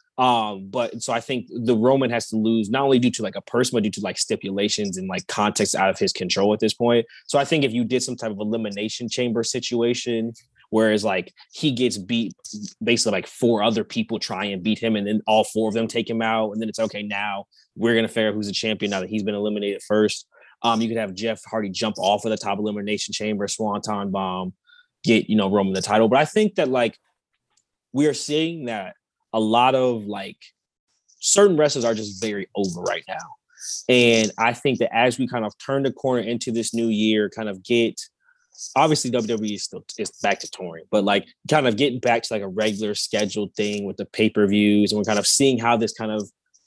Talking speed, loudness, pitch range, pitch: 230 wpm, -22 LUFS, 105-125 Hz, 110 Hz